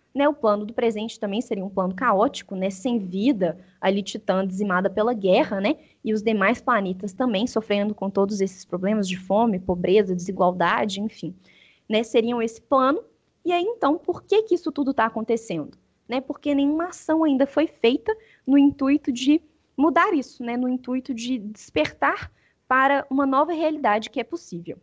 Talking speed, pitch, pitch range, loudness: 175 wpm, 230 Hz, 200-280 Hz, -23 LUFS